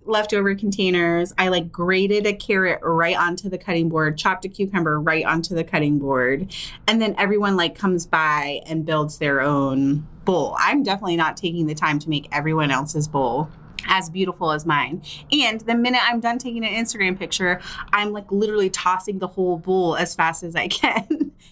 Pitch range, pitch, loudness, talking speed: 160-205 Hz, 180 Hz, -21 LUFS, 185 wpm